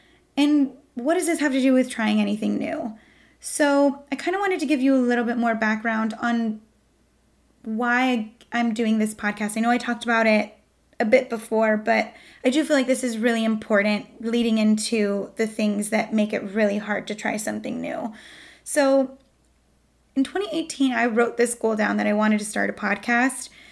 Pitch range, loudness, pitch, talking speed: 220-265 Hz, -23 LUFS, 235 Hz, 190 wpm